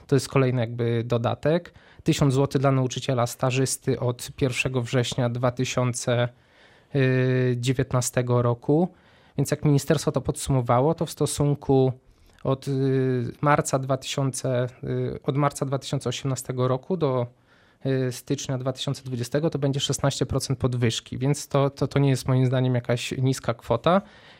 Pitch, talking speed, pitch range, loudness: 130 Hz, 120 wpm, 125-140 Hz, -25 LUFS